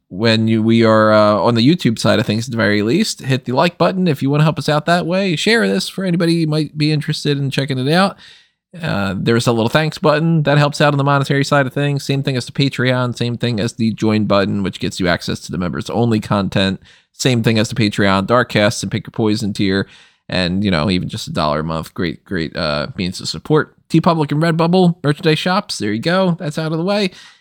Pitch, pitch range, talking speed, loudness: 130 Hz, 110-155 Hz, 250 wpm, -16 LUFS